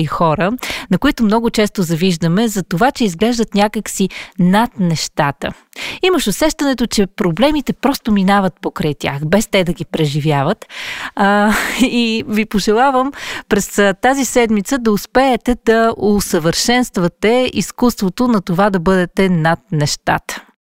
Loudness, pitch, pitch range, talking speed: -15 LUFS, 210 Hz, 185-240 Hz, 130 wpm